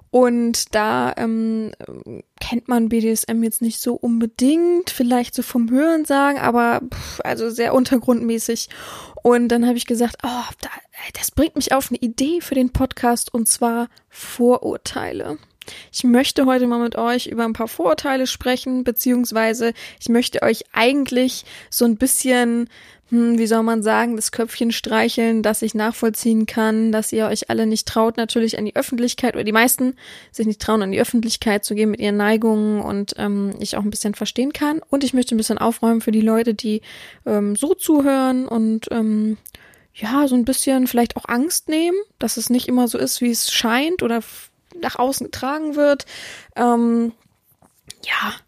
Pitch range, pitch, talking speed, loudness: 225-255 Hz, 235 Hz, 170 wpm, -19 LUFS